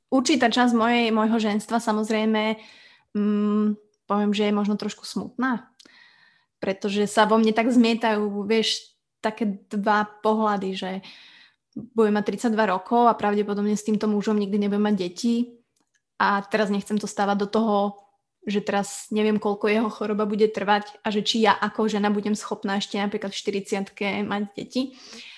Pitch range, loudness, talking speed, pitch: 205-220 Hz, -24 LUFS, 155 wpm, 210 Hz